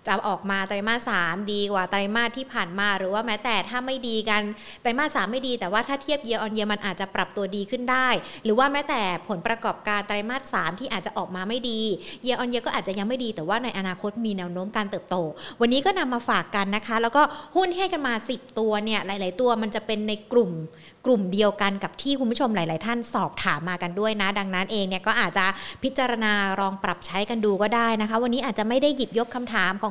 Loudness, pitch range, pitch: -25 LUFS, 195-245 Hz, 215 Hz